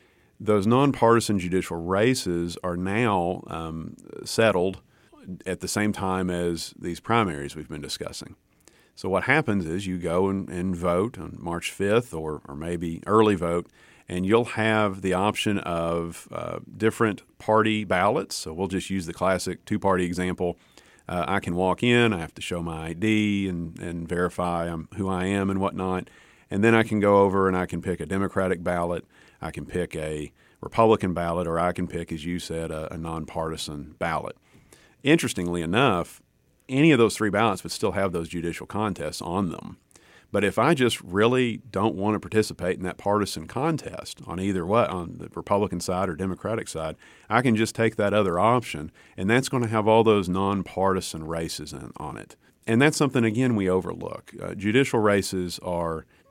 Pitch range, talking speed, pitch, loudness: 85-105 Hz, 180 wpm, 95 Hz, -25 LUFS